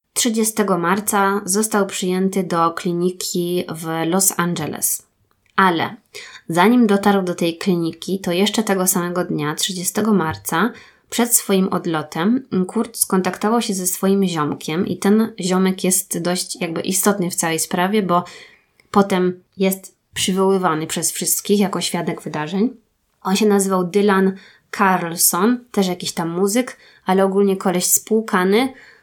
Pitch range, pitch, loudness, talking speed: 175-205 Hz, 190 Hz, -18 LUFS, 130 wpm